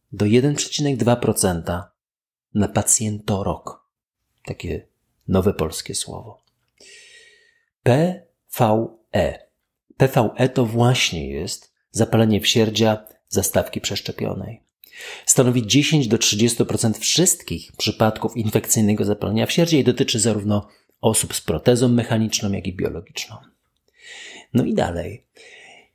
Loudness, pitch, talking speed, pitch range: -20 LUFS, 115 Hz, 90 wpm, 105-140 Hz